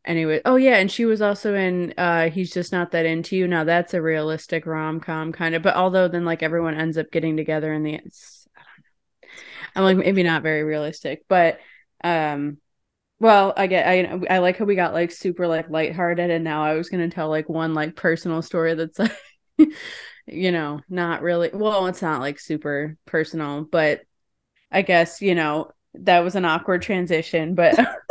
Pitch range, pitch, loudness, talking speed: 160-185 Hz, 170 Hz, -21 LUFS, 200 wpm